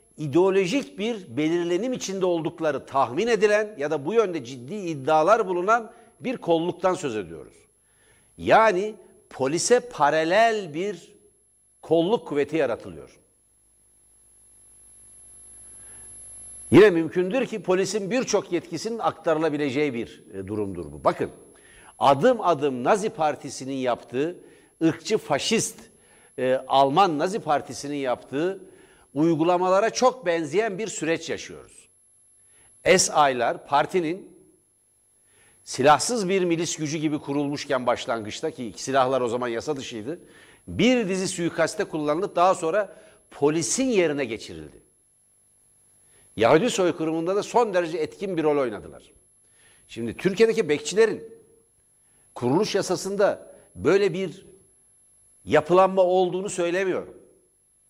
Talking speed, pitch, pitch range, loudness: 100 wpm, 165 Hz, 140-200 Hz, -23 LUFS